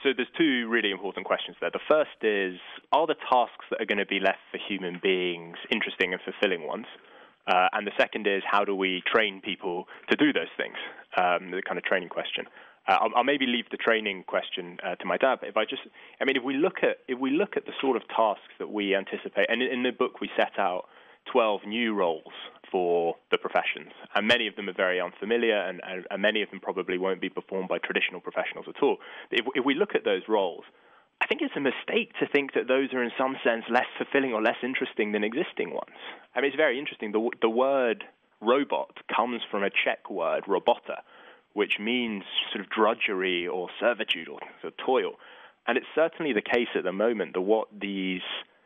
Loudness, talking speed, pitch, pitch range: -27 LUFS, 220 wpm, 115 Hz, 95-130 Hz